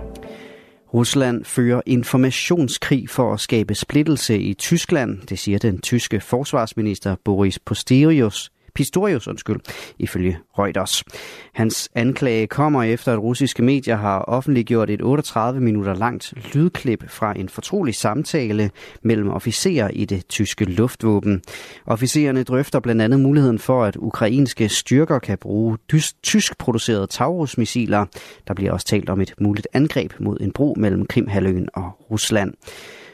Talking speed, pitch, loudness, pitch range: 135 wpm, 115 Hz, -20 LUFS, 105-130 Hz